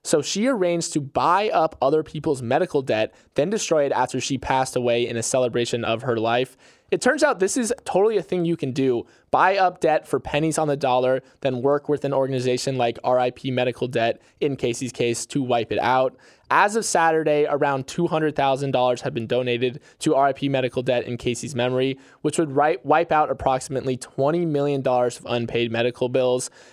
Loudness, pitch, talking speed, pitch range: -22 LUFS, 130 Hz, 190 wpm, 125-150 Hz